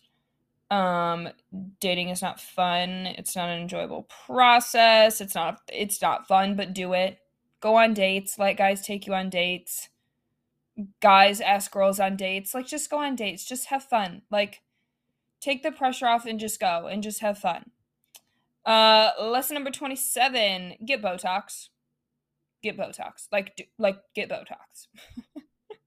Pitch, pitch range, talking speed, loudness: 200 Hz, 190-230 Hz, 150 wpm, -24 LUFS